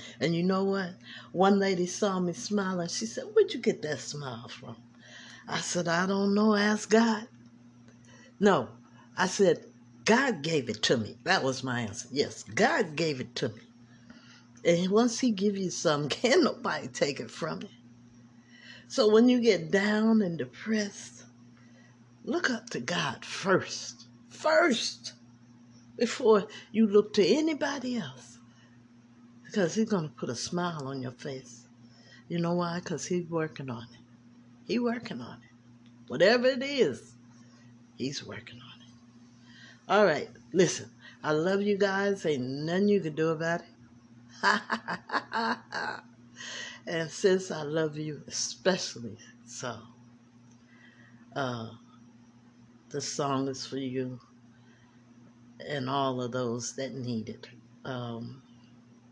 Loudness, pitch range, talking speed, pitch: -29 LUFS, 120-185 Hz, 135 wpm, 125 Hz